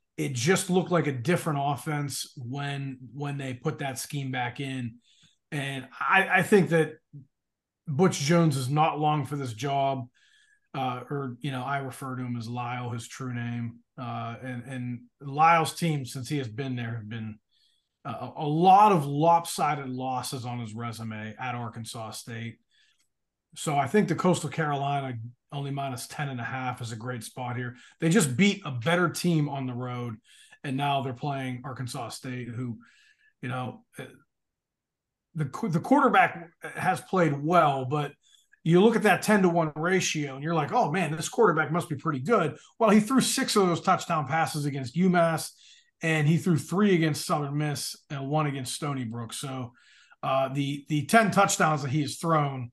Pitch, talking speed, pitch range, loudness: 145 Hz, 180 wpm, 125-165 Hz, -27 LUFS